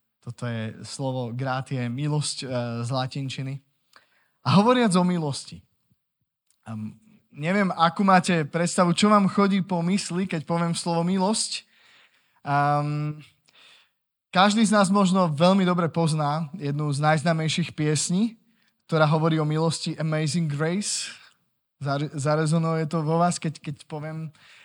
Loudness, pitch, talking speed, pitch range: -24 LUFS, 160 Hz, 125 wpm, 145-180 Hz